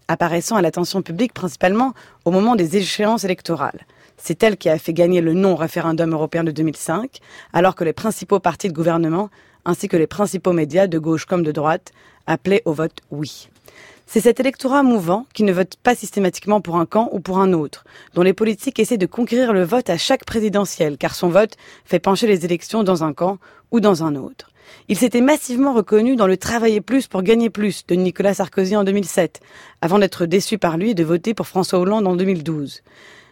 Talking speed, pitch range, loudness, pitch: 200 wpm, 170-215 Hz, -18 LUFS, 185 Hz